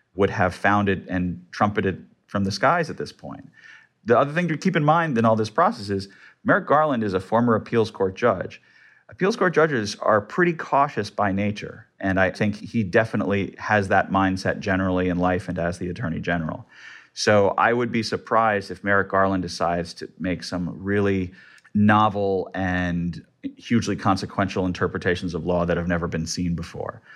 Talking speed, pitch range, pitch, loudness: 180 wpm, 90-110 Hz, 100 Hz, -23 LUFS